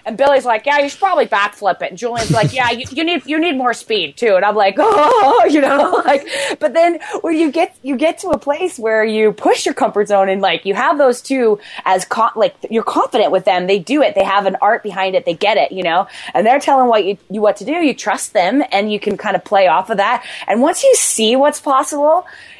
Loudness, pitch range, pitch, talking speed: -14 LUFS, 205-300 Hz, 245 Hz, 260 wpm